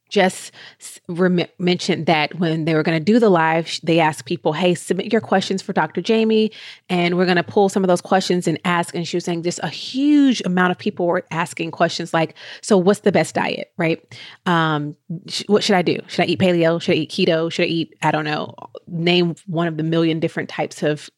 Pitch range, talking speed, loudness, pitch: 165-190 Hz, 230 wpm, -19 LUFS, 175 Hz